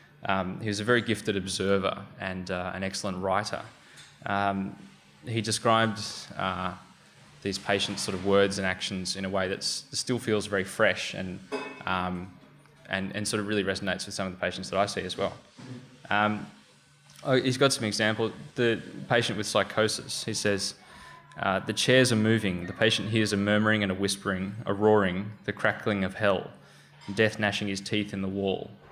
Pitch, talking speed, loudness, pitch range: 100 Hz, 180 wpm, -28 LUFS, 95-110 Hz